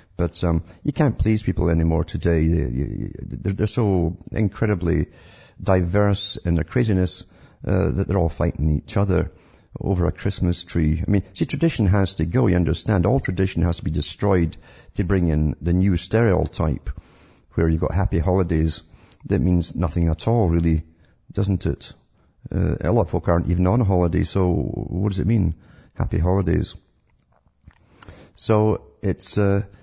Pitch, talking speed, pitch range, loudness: 90 Hz, 160 wpm, 85-100 Hz, -22 LUFS